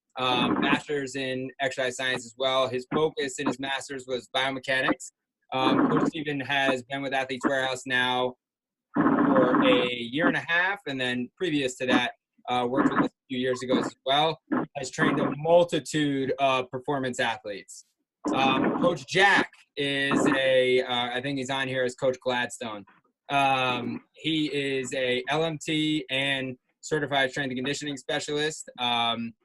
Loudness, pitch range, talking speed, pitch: -26 LUFS, 125-140 Hz, 155 wpm, 130 Hz